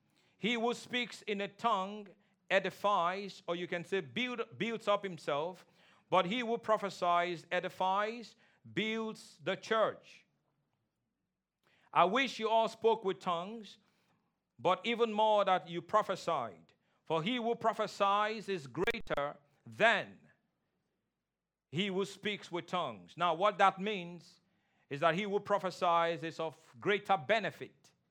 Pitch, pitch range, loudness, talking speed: 195 Hz, 175-215 Hz, -34 LUFS, 130 wpm